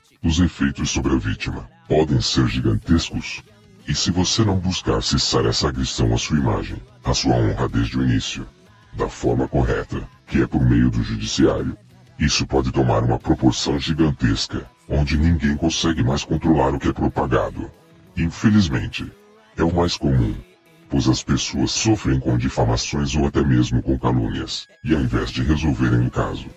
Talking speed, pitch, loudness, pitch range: 165 wpm, 70 Hz, -20 LUFS, 65-85 Hz